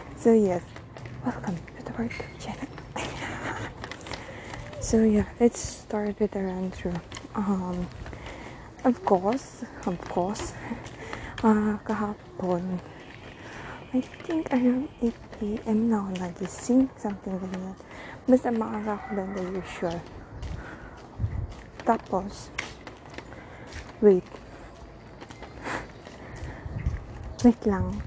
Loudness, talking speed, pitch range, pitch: -28 LUFS, 95 wpm, 180-225 Hz, 200 Hz